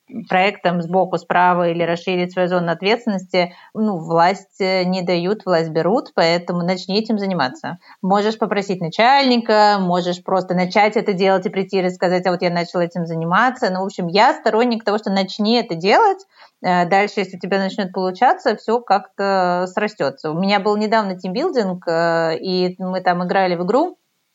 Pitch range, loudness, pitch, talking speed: 180-210 Hz, -18 LUFS, 190 Hz, 165 wpm